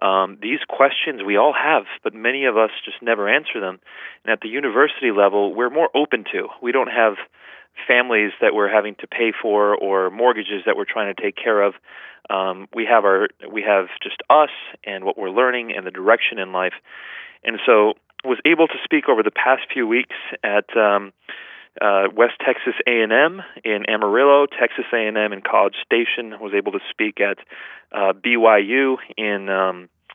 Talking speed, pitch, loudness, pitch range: 185 wpm, 105 Hz, -19 LUFS, 100-125 Hz